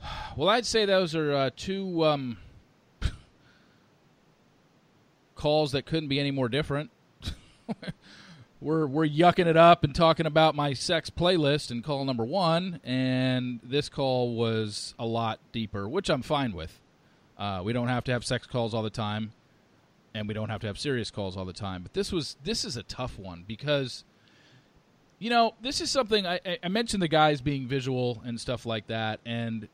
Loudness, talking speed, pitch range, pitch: -28 LUFS, 180 wpm, 115-165 Hz, 135 Hz